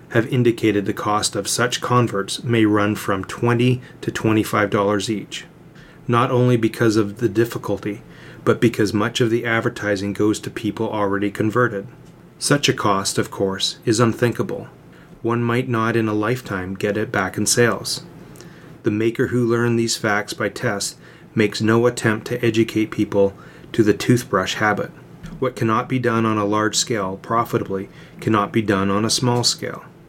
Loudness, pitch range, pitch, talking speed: -20 LUFS, 105-120 Hz, 115 Hz, 170 wpm